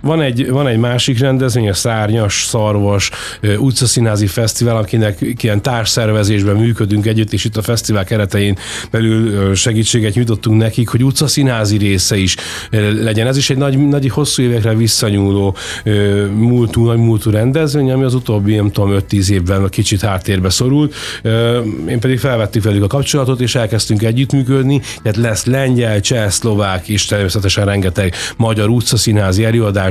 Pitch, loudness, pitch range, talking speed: 110 Hz, -13 LUFS, 105-125 Hz, 145 wpm